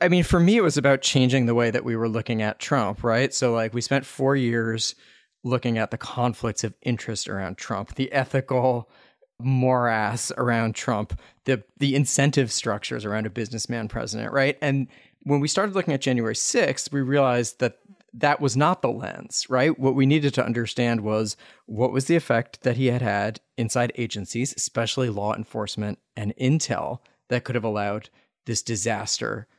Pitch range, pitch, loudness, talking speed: 115-135 Hz, 120 Hz, -24 LUFS, 180 wpm